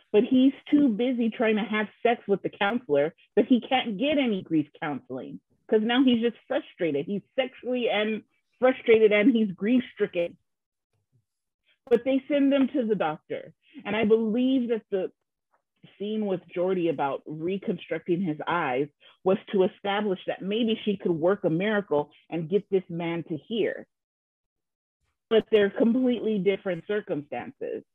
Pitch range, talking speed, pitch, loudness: 175-240 Hz, 150 wpm, 210 Hz, -26 LUFS